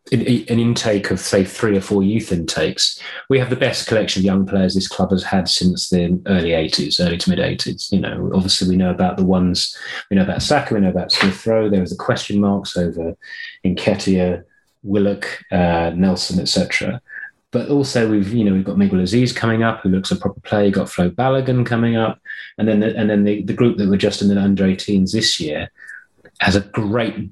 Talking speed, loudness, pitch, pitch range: 215 wpm, -17 LUFS, 100 Hz, 95-110 Hz